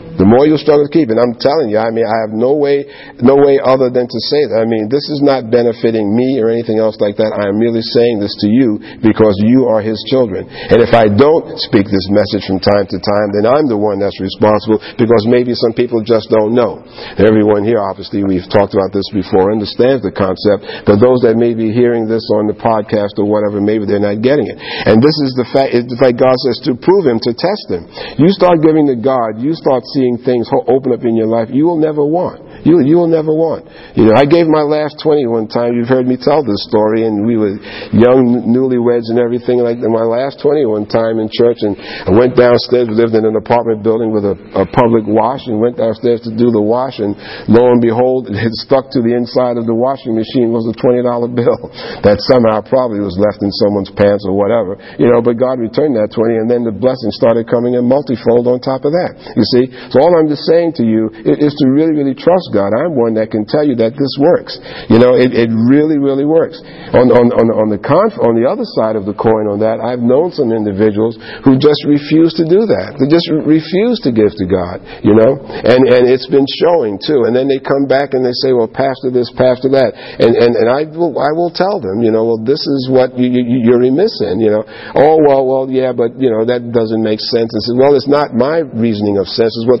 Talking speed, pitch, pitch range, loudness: 250 wpm, 120 Hz, 110-130 Hz, -12 LUFS